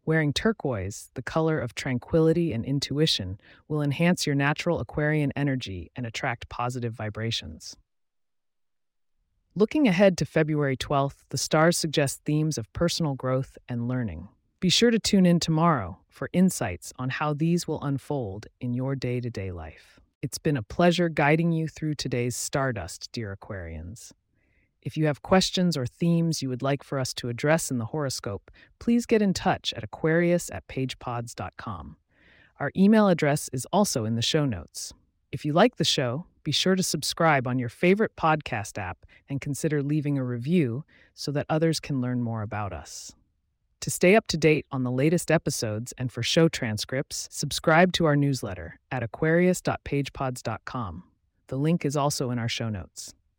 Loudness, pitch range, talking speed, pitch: -26 LUFS, 120-160 Hz, 165 wpm, 140 Hz